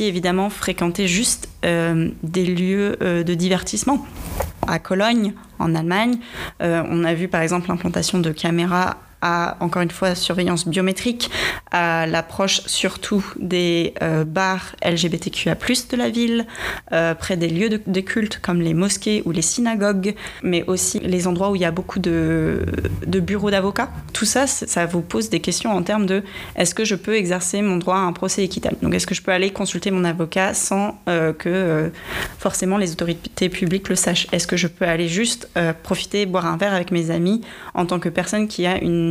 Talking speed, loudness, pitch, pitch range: 195 wpm, -20 LUFS, 185 Hz, 170-205 Hz